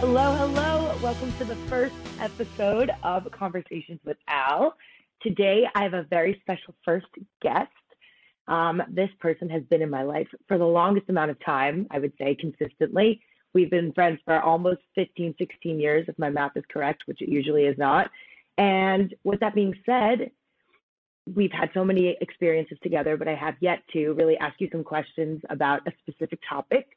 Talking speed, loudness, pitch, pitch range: 180 wpm, -25 LUFS, 175 Hz, 160-200 Hz